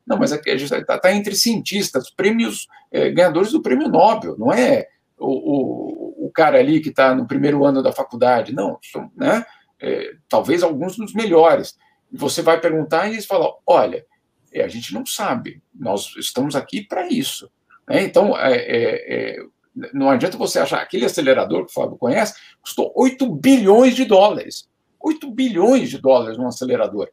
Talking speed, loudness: 175 wpm, -18 LUFS